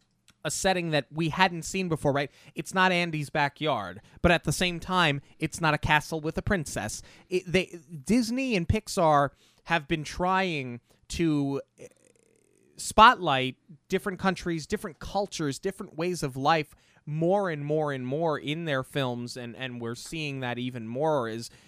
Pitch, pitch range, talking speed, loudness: 155 Hz, 140-180 Hz, 160 wpm, -27 LUFS